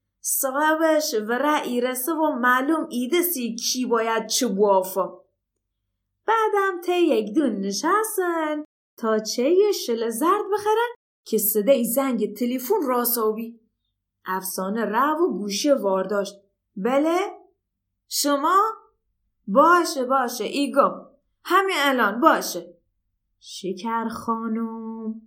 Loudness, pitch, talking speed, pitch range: -22 LUFS, 245 Hz, 105 wpm, 210-315 Hz